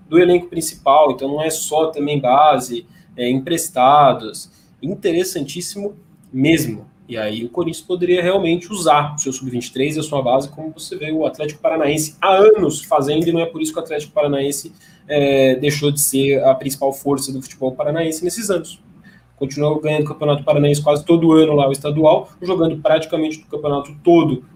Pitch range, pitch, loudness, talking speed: 140-170 Hz, 155 Hz, -17 LUFS, 180 wpm